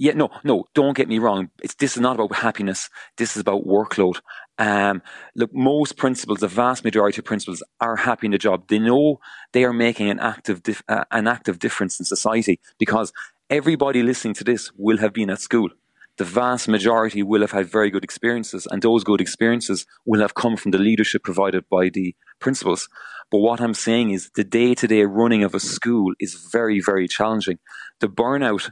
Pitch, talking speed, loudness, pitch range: 110 Hz, 200 wpm, -20 LUFS, 100-120 Hz